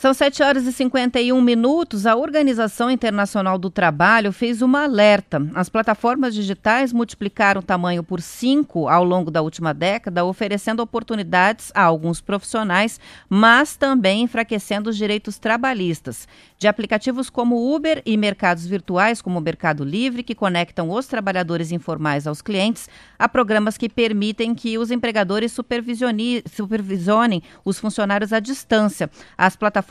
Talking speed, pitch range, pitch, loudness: 145 wpm, 185-235 Hz, 215 Hz, -19 LUFS